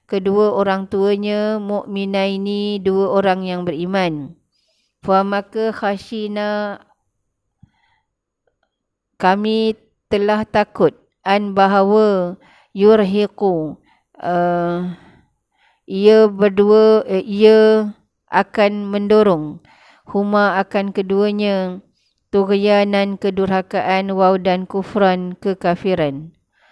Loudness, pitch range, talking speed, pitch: -17 LUFS, 190-210 Hz, 70 wpm, 200 Hz